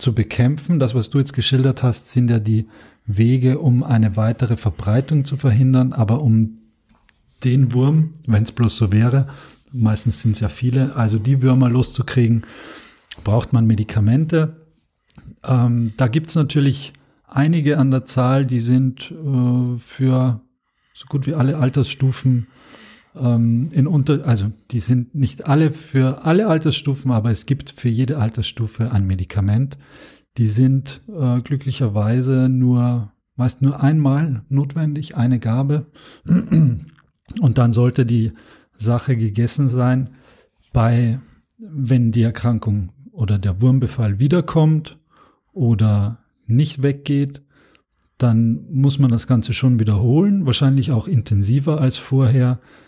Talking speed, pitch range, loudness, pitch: 130 wpm, 115-140 Hz, -18 LUFS, 125 Hz